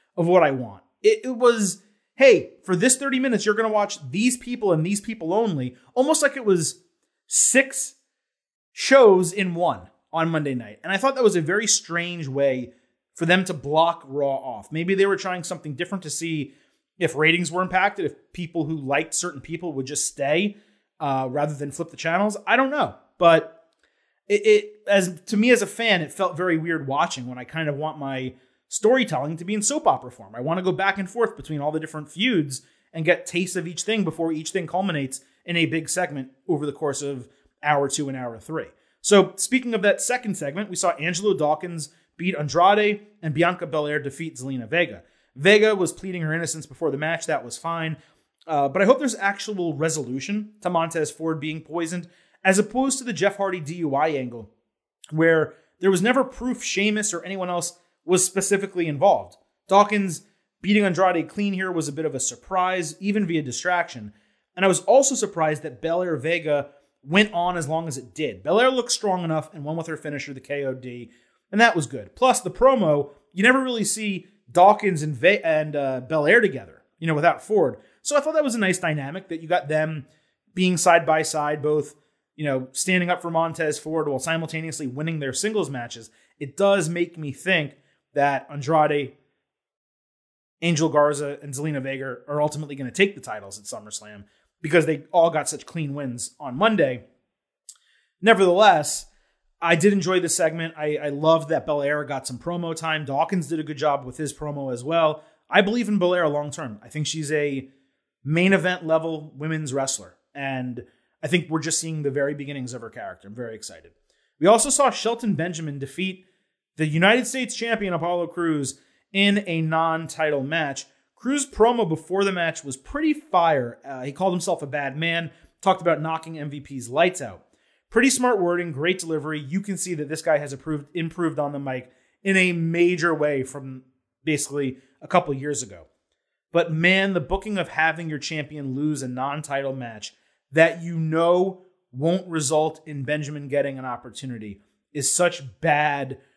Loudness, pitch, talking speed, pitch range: -23 LUFS, 165 Hz, 190 wpm, 145-190 Hz